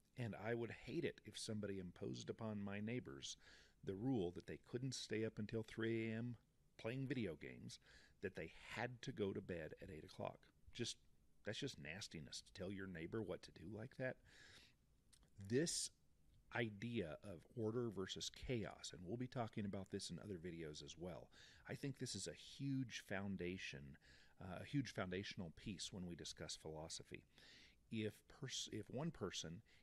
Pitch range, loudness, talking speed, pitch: 95-120 Hz, -49 LUFS, 170 wpm, 105 Hz